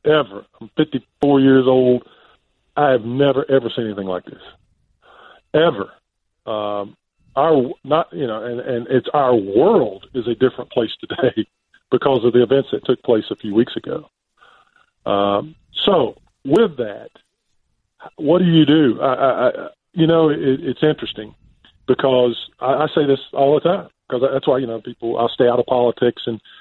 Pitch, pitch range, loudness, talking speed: 125 Hz, 115-135 Hz, -18 LUFS, 175 wpm